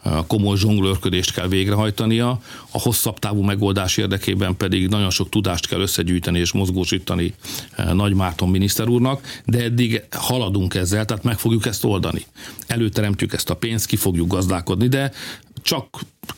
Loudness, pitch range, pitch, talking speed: -20 LUFS, 95-115 Hz, 100 Hz, 145 wpm